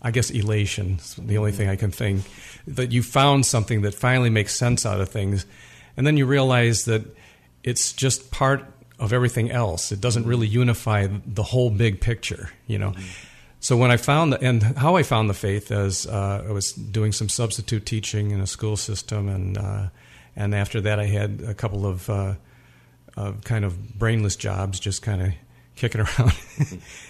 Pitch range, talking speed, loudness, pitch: 100-120 Hz, 180 wpm, -23 LUFS, 110 Hz